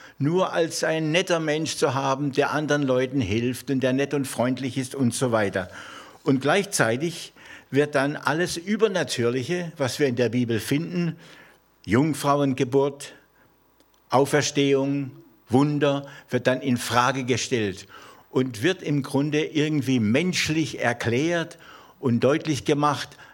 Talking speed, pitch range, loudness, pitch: 130 wpm, 130-150 Hz, -24 LUFS, 140 Hz